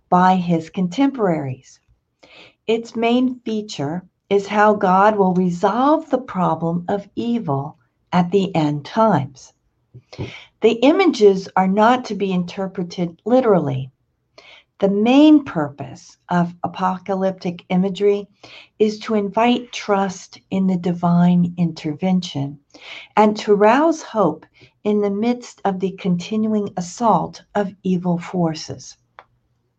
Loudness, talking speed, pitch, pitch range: -19 LUFS, 110 wpm, 190 Hz, 165-210 Hz